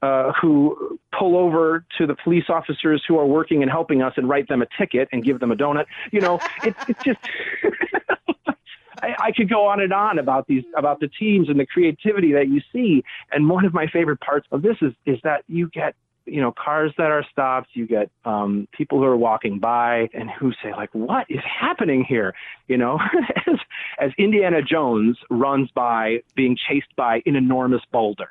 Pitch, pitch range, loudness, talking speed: 150 Hz, 130-185 Hz, -20 LUFS, 205 wpm